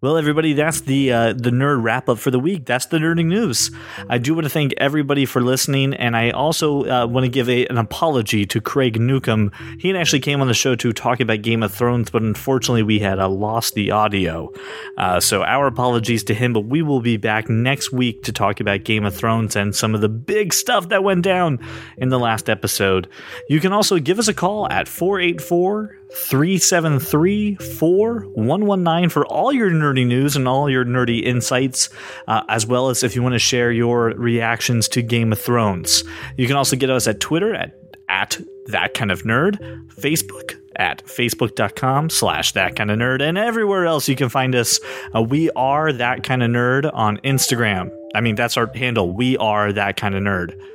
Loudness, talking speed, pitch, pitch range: -18 LUFS, 210 wpm, 125 Hz, 110-145 Hz